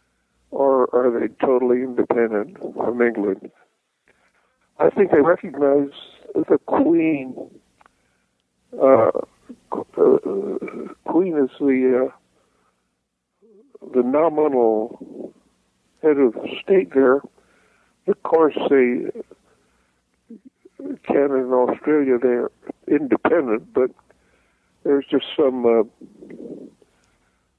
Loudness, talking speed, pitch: -19 LUFS, 80 wpm, 140 Hz